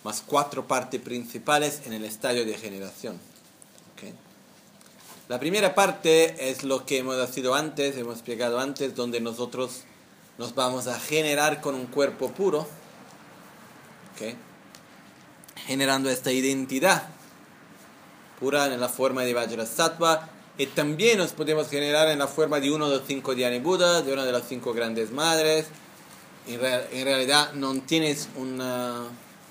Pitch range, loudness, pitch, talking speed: 125-150 Hz, -25 LUFS, 135 Hz, 145 wpm